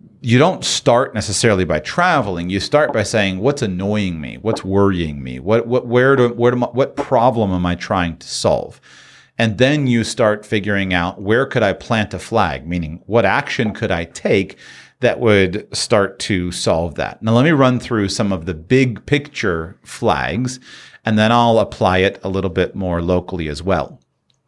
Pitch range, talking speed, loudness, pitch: 90-120 Hz, 190 wpm, -17 LUFS, 105 Hz